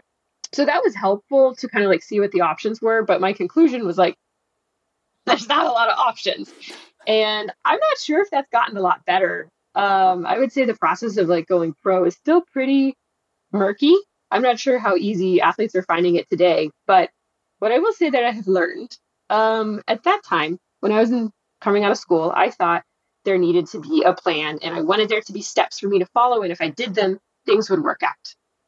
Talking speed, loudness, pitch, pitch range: 225 wpm, -19 LUFS, 215 Hz, 185-265 Hz